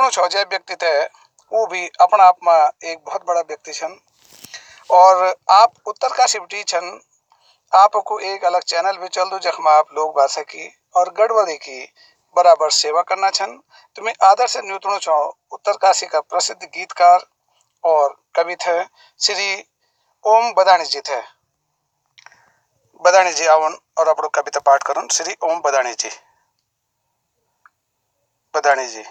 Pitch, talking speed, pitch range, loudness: 180 Hz, 150 wpm, 155-195 Hz, -16 LUFS